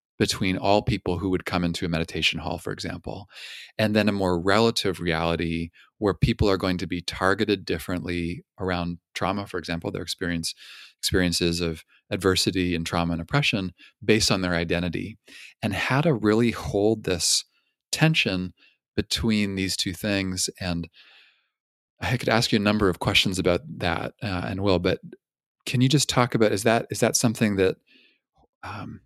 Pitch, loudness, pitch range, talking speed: 95 Hz, -24 LUFS, 85-110 Hz, 165 wpm